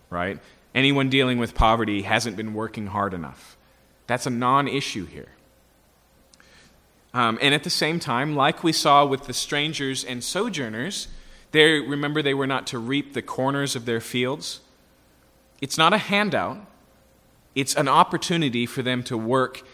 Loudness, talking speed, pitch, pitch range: -23 LUFS, 155 wpm, 130 Hz, 115-145 Hz